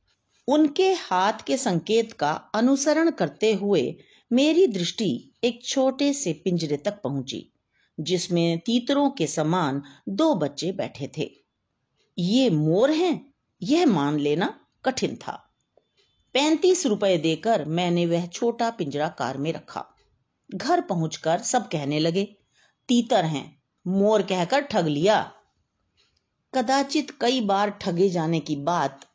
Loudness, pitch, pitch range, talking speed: -24 LUFS, 200 Hz, 165-260 Hz, 125 wpm